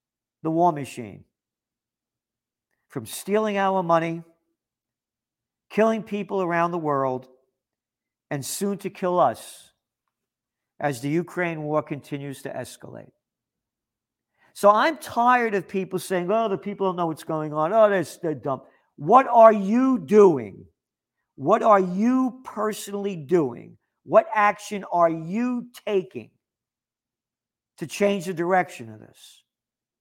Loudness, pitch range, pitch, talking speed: -22 LUFS, 140-205 Hz, 180 Hz, 125 wpm